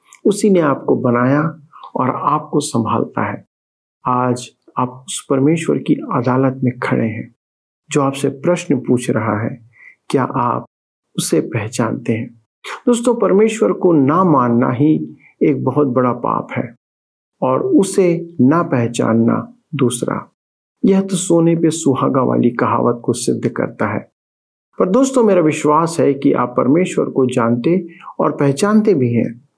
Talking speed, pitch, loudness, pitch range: 140 wpm, 135 Hz, -16 LUFS, 115-165 Hz